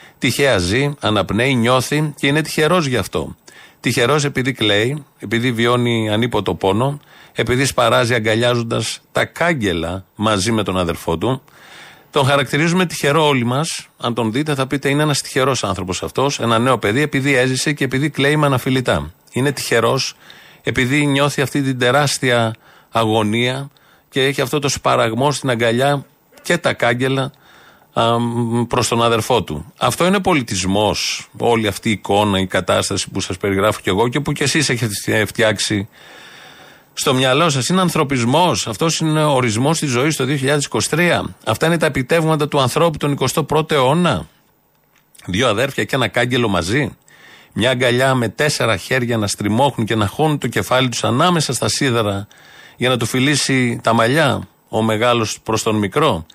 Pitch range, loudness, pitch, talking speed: 110-145 Hz, -17 LUFS, 125 Hz, 160 wpm